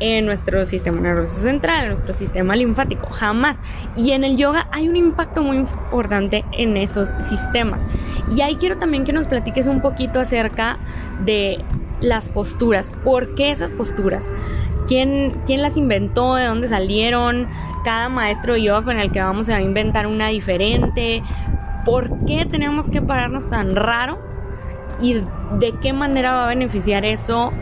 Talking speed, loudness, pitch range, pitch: 165 wpm, -19 LUFS, 205-270 Hz, 235 Hz